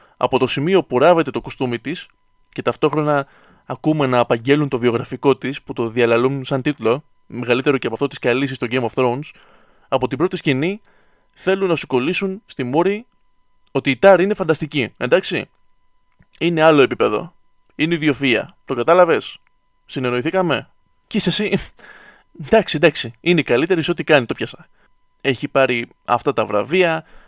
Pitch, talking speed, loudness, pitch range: 145 Hz, 160 wpm, -18 LUFS, 125-175 Hz